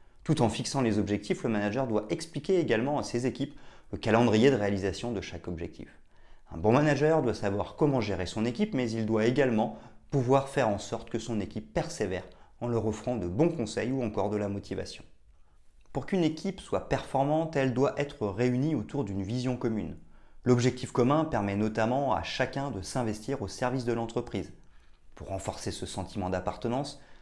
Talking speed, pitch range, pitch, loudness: 180 wpm, 105-135 Hz, 115 Hz, -30 LUFS